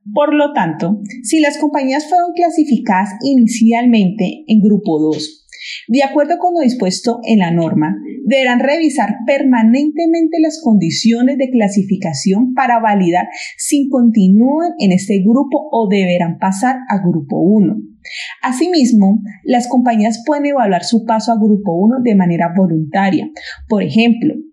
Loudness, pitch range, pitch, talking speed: -13 LUFS, 200-280 Hz, 230 Hz, 135 wpm